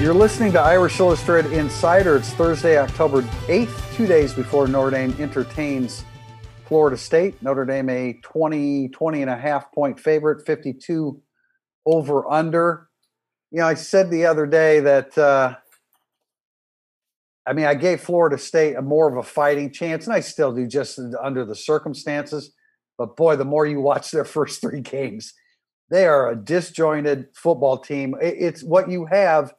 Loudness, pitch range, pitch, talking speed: -20 LUFS, 135-160 Hz, 145 Hz, 160 wpm